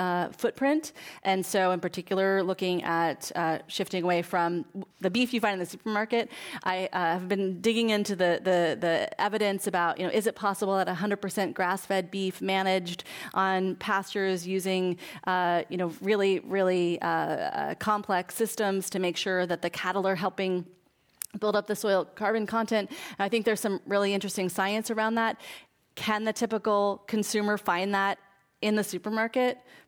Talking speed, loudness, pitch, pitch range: 170 wpm, -28 LUFS, 195 Hz, 180-210 Hz